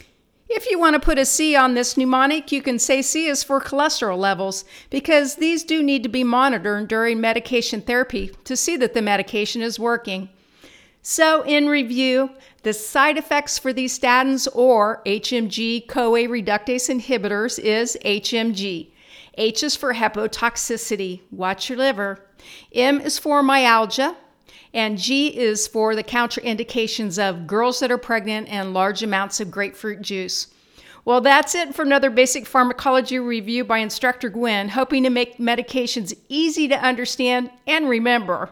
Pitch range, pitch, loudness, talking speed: 220-270 Hz, 245 Hz, -20 LUFS, 155 wpm